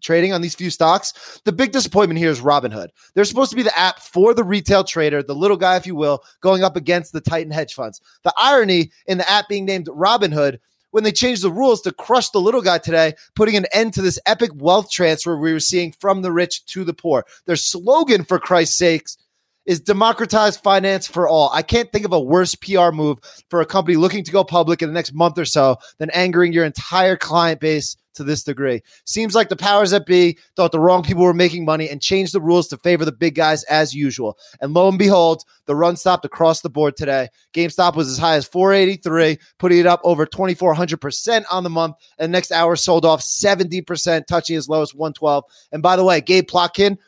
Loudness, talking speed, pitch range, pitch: -17 LUFS, 225 wpm, 160-190 Hz, 175 Hz